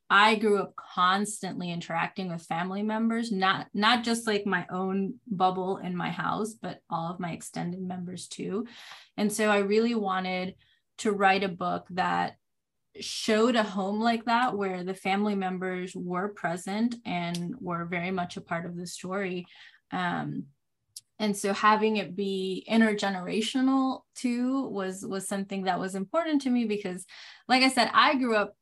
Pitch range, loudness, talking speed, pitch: 180-220 Hz, -28 LUFS, 165 wpm, 195 Hz